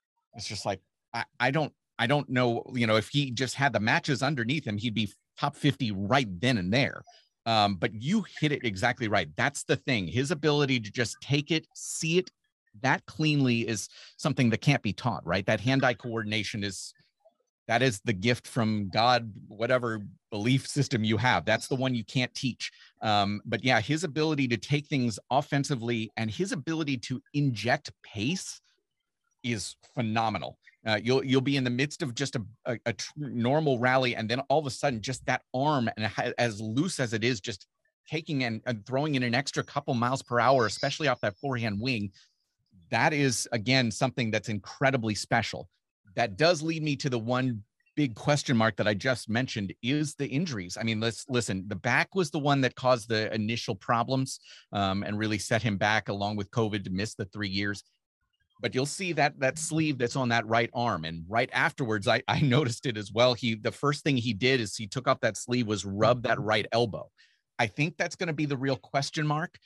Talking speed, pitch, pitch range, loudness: 205 wpm, 125 Hz, 110-140 Hz, -28 LUFS